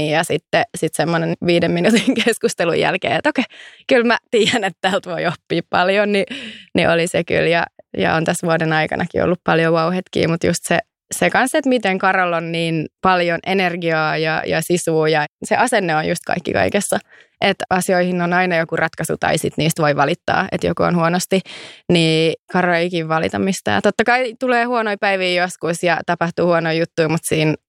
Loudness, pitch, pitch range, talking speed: -17 LUFS, 175 Hz, 165-195 Hz, 190 wpm